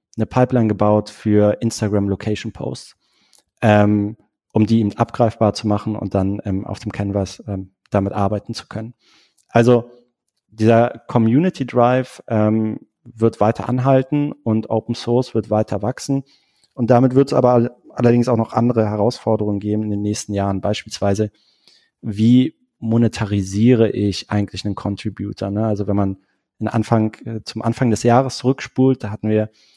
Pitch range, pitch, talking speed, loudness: 105-120 Hz, 110 Hz, 150 wpm, -18 LUFS